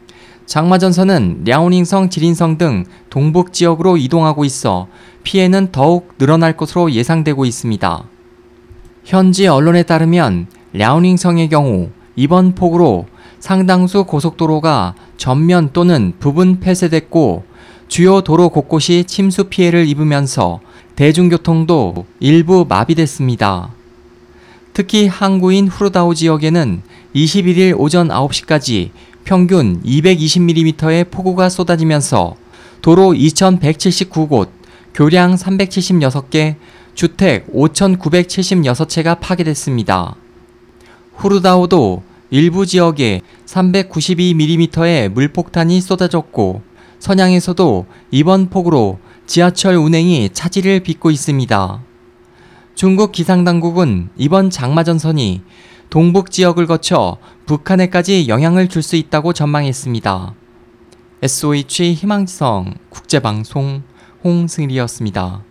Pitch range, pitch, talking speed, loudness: 120-180 Hz, 160 Hz, 240 characters per minute, -12 LUFS